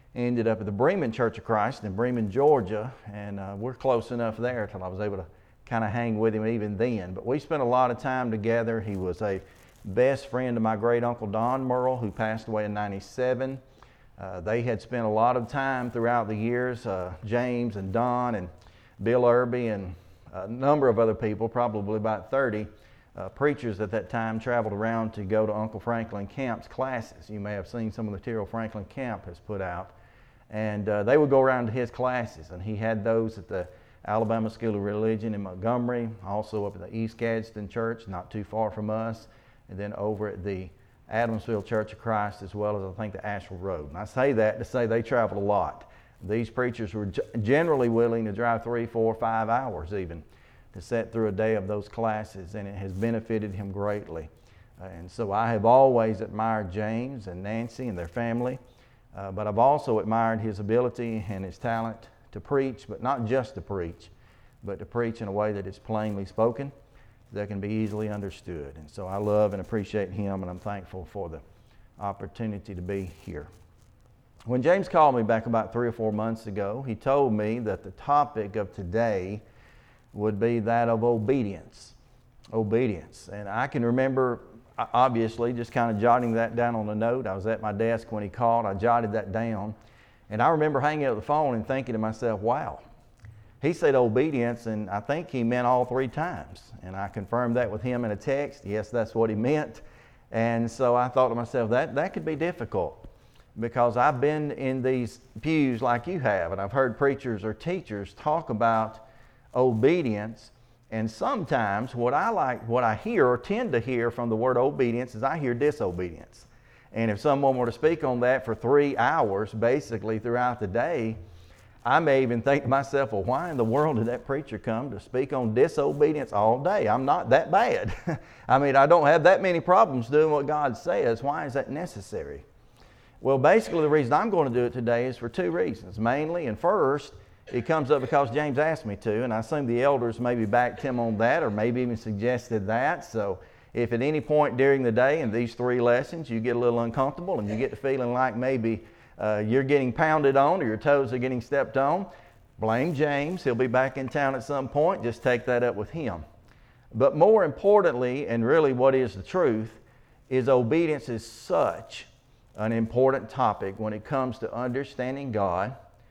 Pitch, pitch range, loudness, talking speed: 115 Hz, 105-125 Hz, -27 LUFS, 200 wpm